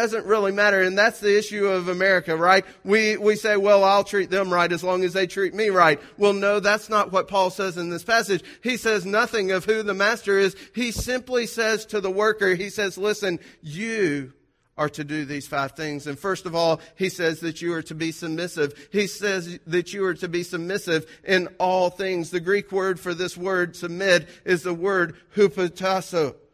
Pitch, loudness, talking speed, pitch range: 190 Hz, -23 LUFS, 210 wpm, 175-205 Hz